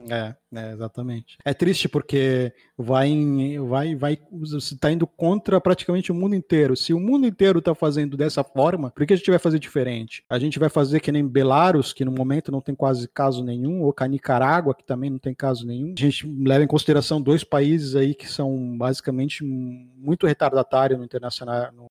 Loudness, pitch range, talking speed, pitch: -22 LUFS, 130-155 Hz, 195 wpm, 140 Hz